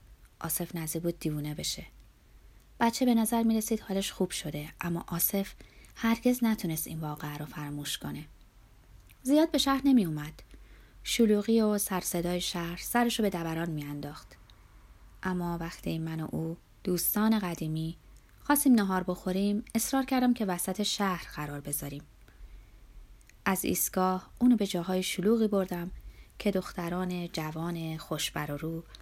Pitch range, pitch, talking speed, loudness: 160-210 Hz, 175 Hz, 135 wpm, -30 LUFS